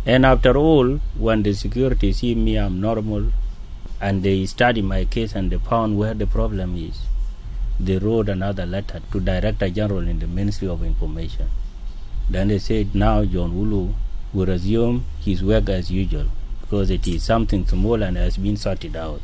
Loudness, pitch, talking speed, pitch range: -22 LUFS, 100 Hz, 175 wpm, 90-110 Hz